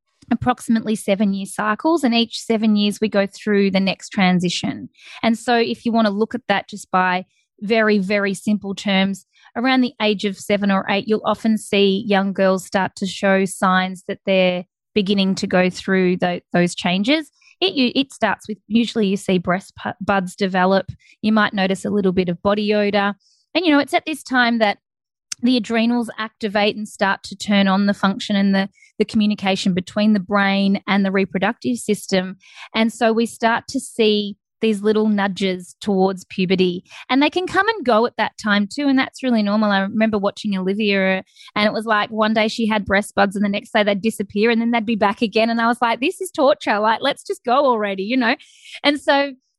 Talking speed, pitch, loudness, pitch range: 205 wpm, 210 Hz, -19 LUFS, 195-235 Hz